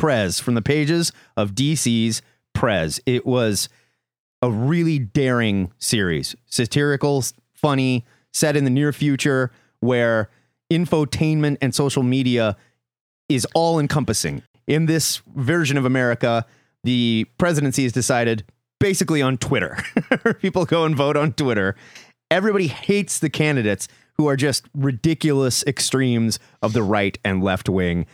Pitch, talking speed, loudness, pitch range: 130 Hz, 130 wpm, -20 LUFS, 115-150 Hz